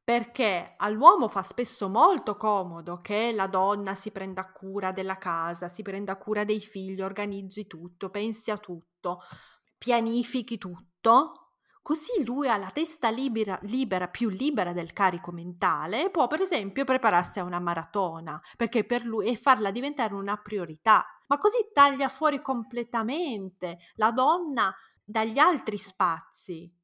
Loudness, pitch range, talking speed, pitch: -27 LUFS, 190-245 Hz, 145 wpm, 210 Hz